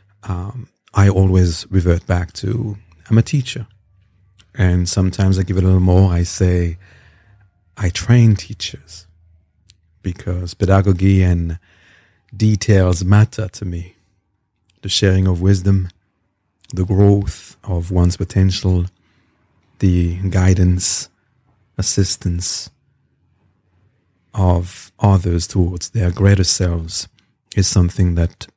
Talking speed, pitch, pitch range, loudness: 105 wpm, 95 Hz, 90-100 Hz, -16 LUFS